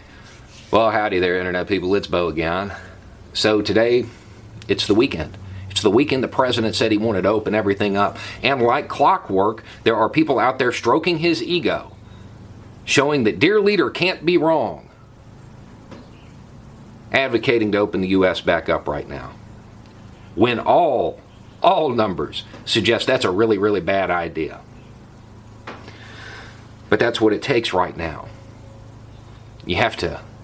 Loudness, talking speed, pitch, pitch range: -19 LUFS, 145 wpm, 110 Hz, 100-115 Hz